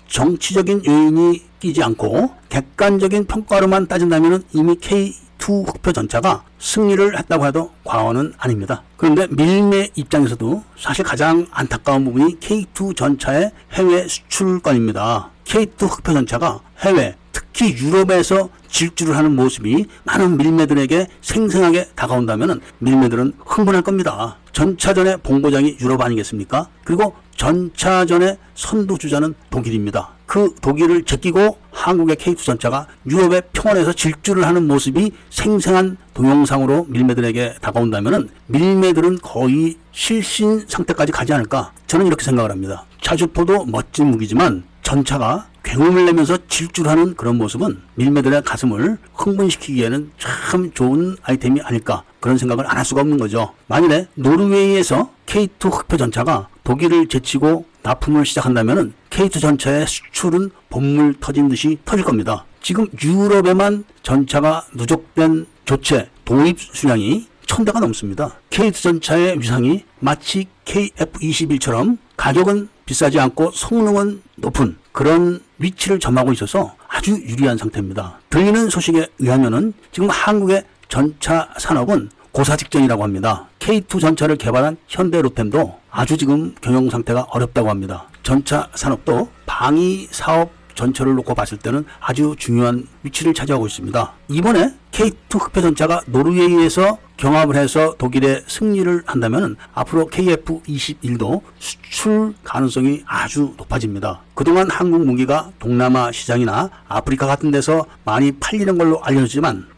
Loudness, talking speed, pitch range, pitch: -17 LUFS, 325 characters per minute, 130-180 Hz, 155 Hz